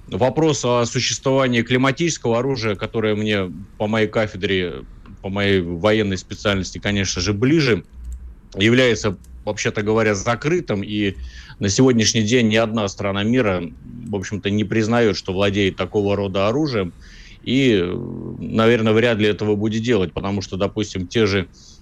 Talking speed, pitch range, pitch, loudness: 140 wpm, 100-115 Hz, 105 Hz, -19 LUFS